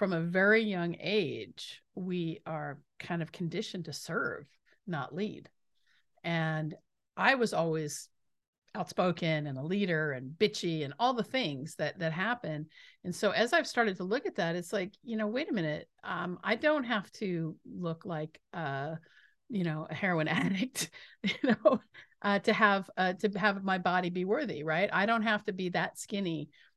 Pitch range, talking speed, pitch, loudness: 160-210 Hz, 180 wpm, 180 Hz, -32 LUFS